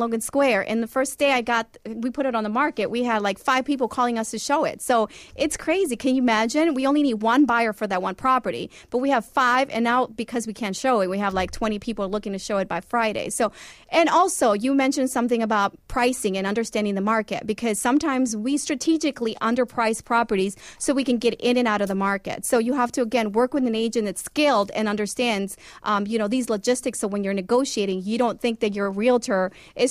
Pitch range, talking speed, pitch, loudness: 215-260 Hz, 235 wpm, 235 Hz, -23 LUFS